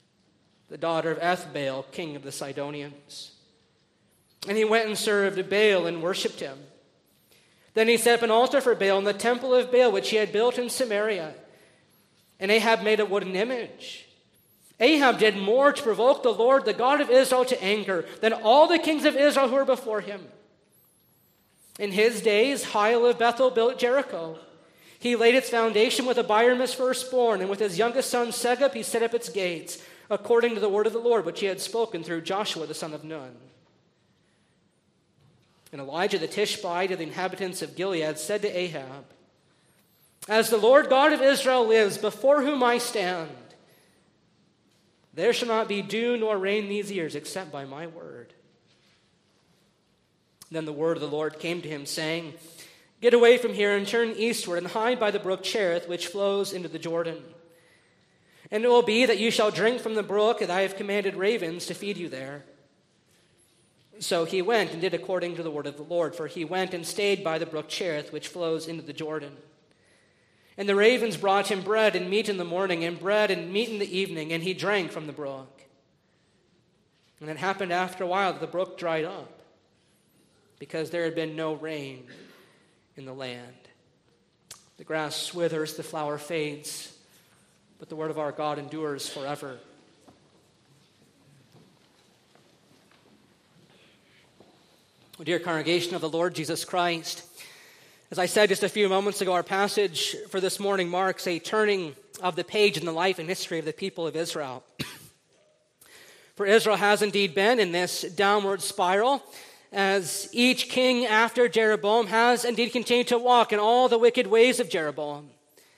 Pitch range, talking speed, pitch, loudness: 165-225 Hz, 175 wpm, 195 Hz, -25 LUFS